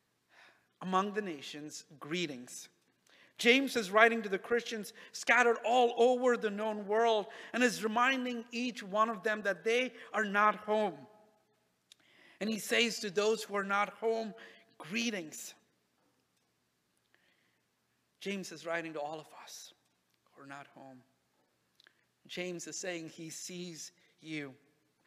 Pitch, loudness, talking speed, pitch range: 205 Hz, -33 LUFS, 130 wpm, 155-225 Hz